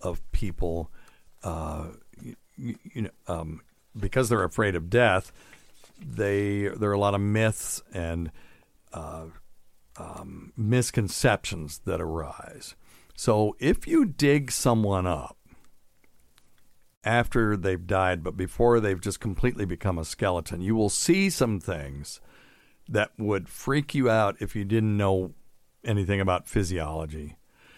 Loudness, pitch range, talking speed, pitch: -27 LUFS, 90-110 Hz, 125 wpm, 100 Hz